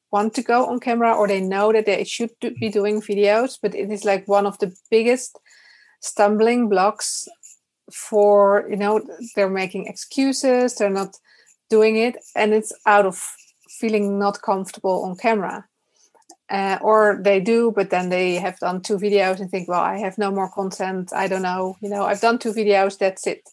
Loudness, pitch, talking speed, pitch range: -20 LUFS, 205 Hz, 190 wpm, 195-225 Hz